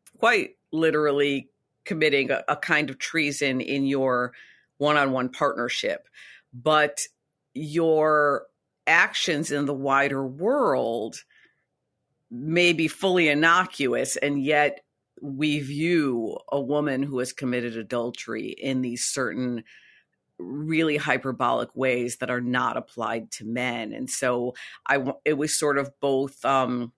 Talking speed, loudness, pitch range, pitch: 120 wpm, -24 LUFS, 125-150 Hz, 140 Hz